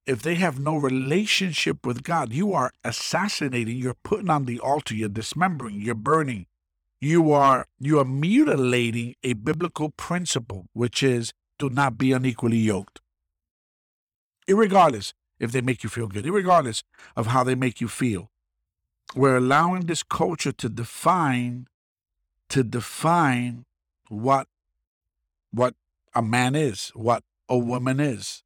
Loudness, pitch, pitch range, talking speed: -23 LUFS, 125 Hz, 110-150 Hz, 135 wpm